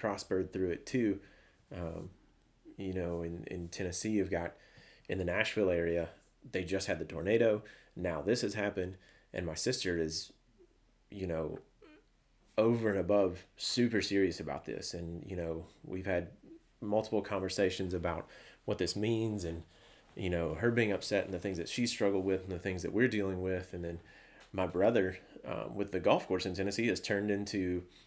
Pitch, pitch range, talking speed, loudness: 95 Hz, 85-100 Hz, 175 wpm, -35 LUFS